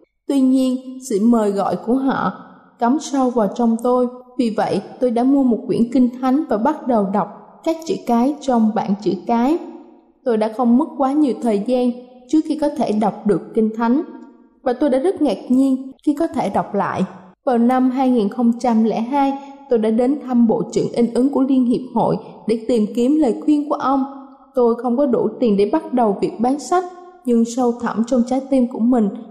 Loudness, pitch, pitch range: -18 LUFS, 250 Hz, 230-275 Hz